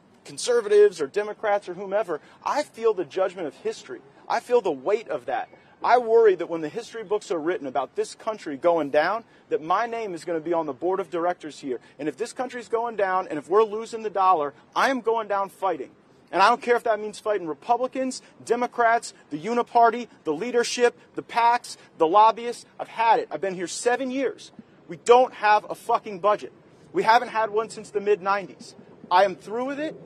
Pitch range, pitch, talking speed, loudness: 190-240 Hz, 220 Hz, 210 wpm, -24 LUFS